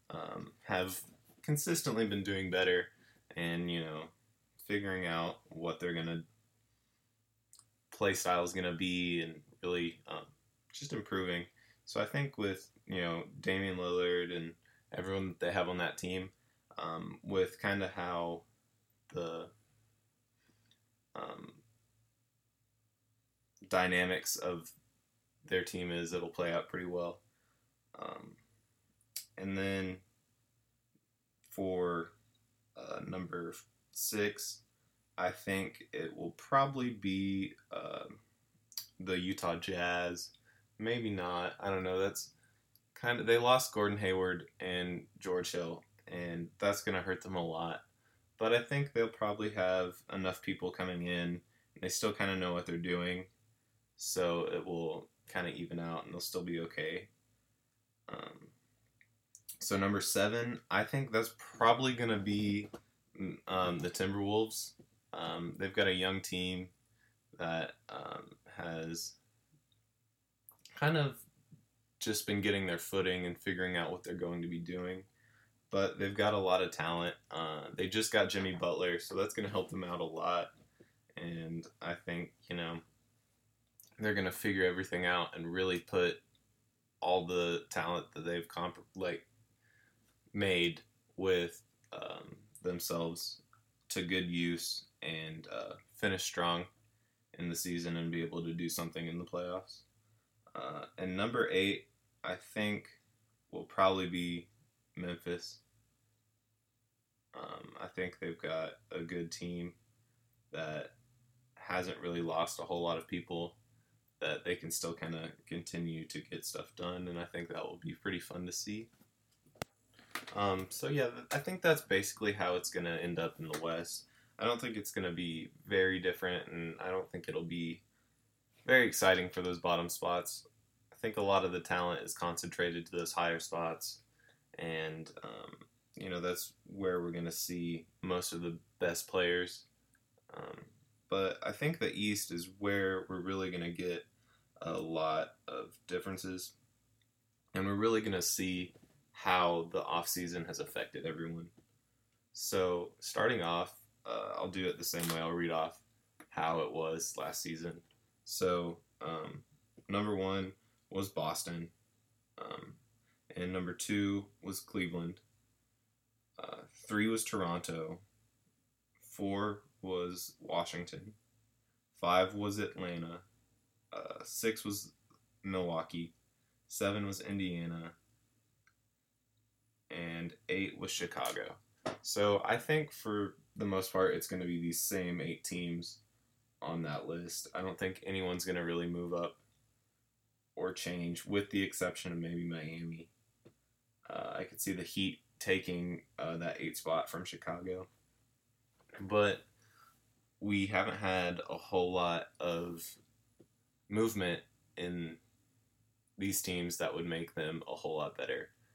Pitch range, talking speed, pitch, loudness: 90-115 Hz, 140 wpm, 95 Hz, -37 LUFS